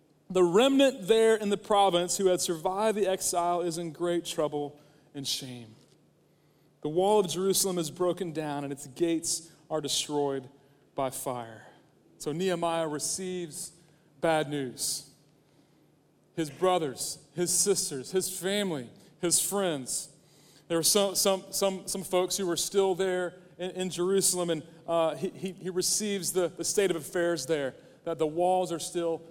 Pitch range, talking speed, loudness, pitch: 150-185 Hz, 155 wpm, -29 LUFS, 170 Hz